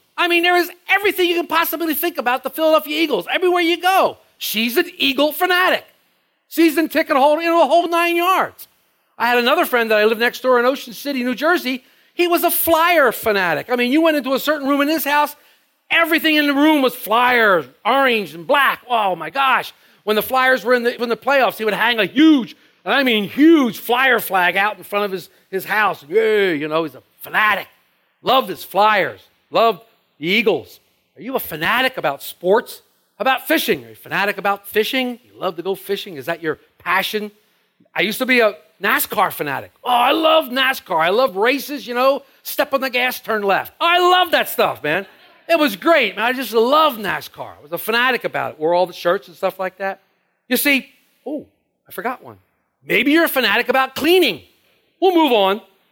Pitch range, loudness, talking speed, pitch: 210-320 Hz, -17 LUFS, 210 wpm, 260 Hz